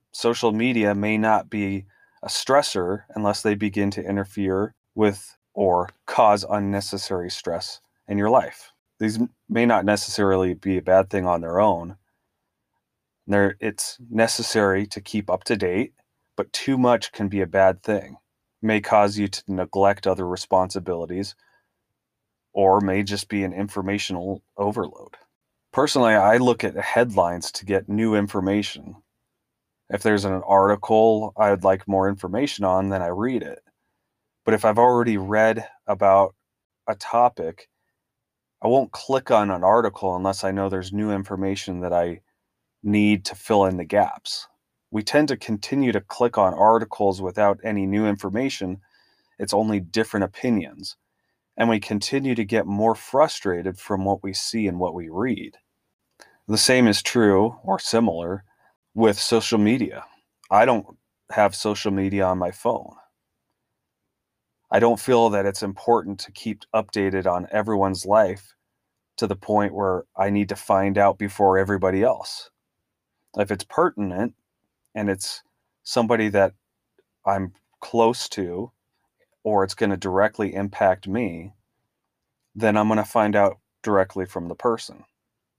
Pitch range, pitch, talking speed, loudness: 95-110 Hz, 100 Hz, 150 wpm, -22 LUFS